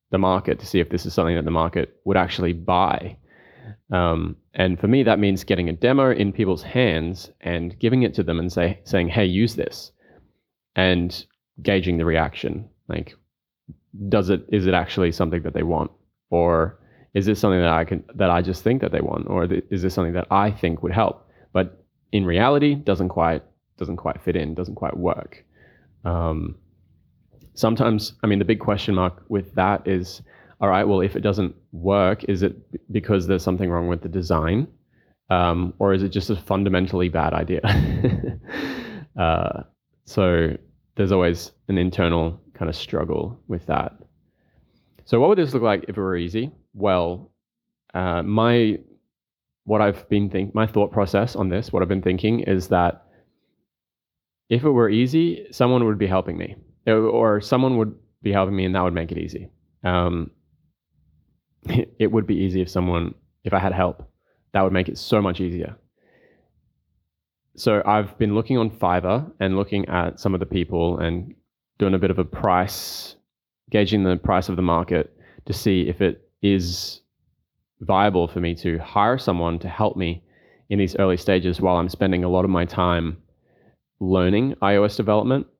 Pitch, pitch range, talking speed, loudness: 95 Hz, 85-105 Hz, 180 wpm, -22 LUFS